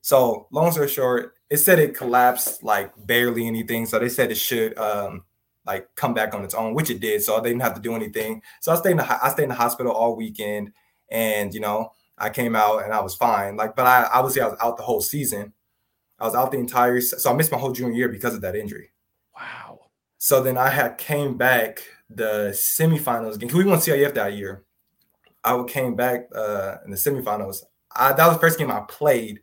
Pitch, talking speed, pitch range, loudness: 120 Hz, 230 wpm, 110-135 Hz, -21 LUFS